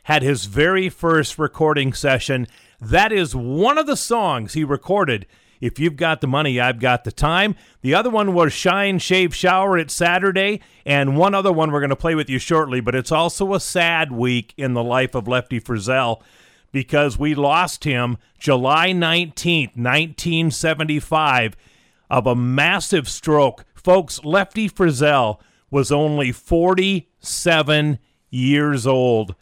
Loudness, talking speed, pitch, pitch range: -18 LUFS, 150 wpm, 150 Hz, 125-175 Hz